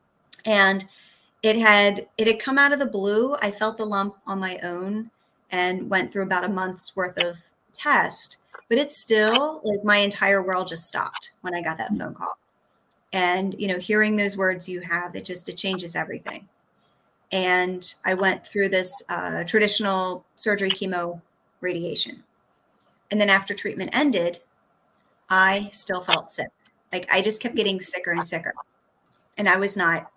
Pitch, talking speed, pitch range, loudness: 195 Hz, 170 wpm, 180-210 Hz, -22 LUFS